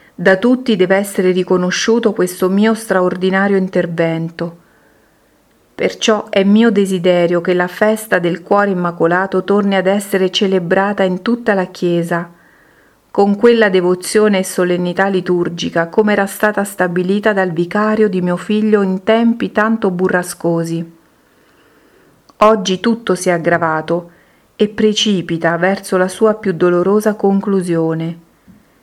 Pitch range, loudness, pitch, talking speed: 180-210 Hz, -14 LUFS, 190 Hz, 125 wpm